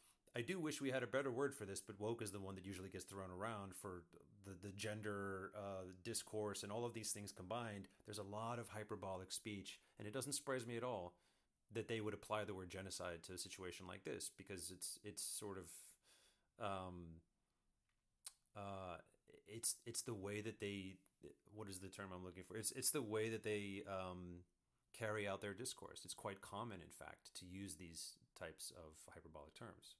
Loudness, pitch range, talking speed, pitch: -48 LUFS, 95-110 Hz, 200 wpm, 100 Hz